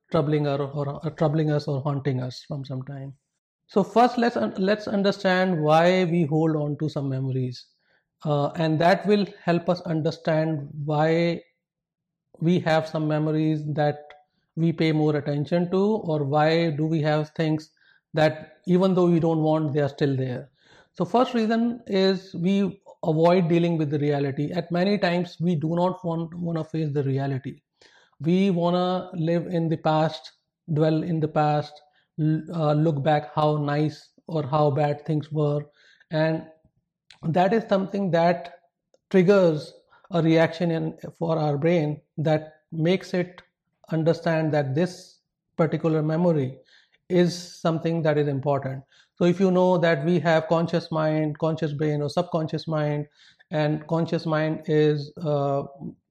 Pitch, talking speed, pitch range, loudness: 160 Hz, 155 wpm, 150-175 Hz, -24 LUFS